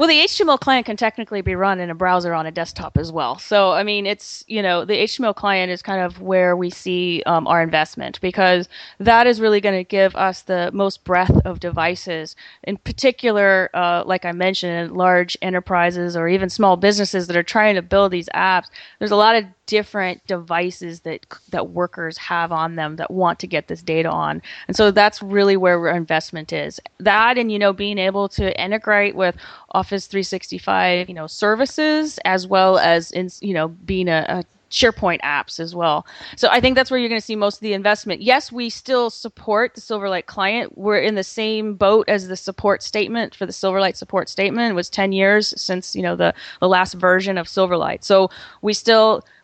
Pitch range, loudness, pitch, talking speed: 175-210 Hz, -18 LUFS, 190 Hz, 205 wpm